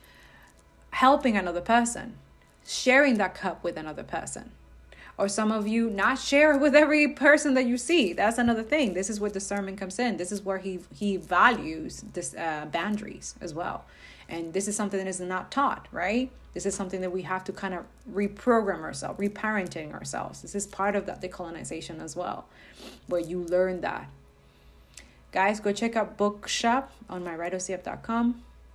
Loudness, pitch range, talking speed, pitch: -27 LUFS, 180-230 Hz, 175 wpm, 200 Hz